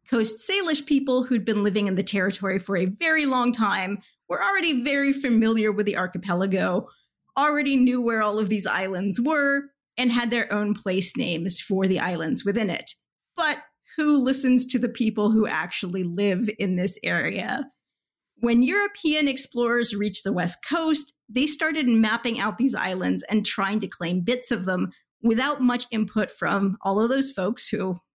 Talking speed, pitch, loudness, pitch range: 175 wpm, 225 Hz, -23 LUFS, 195-265 Hz